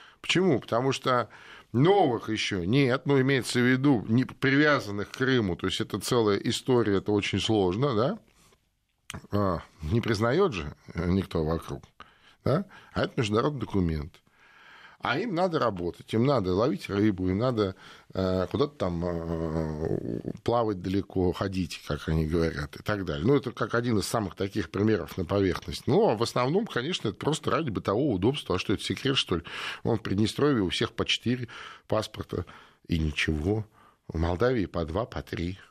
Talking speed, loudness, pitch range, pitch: 165 wpm, -27 LUFS, 90-120 Hz, 100 Hz